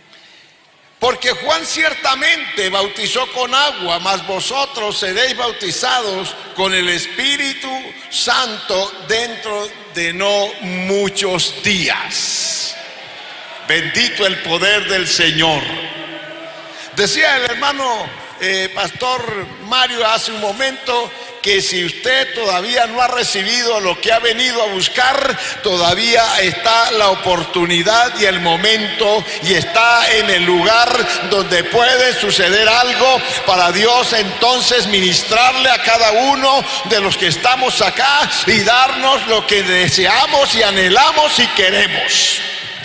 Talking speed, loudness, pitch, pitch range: 115 wpm, -13 LUFS, 225 Hz, 190-255 Hz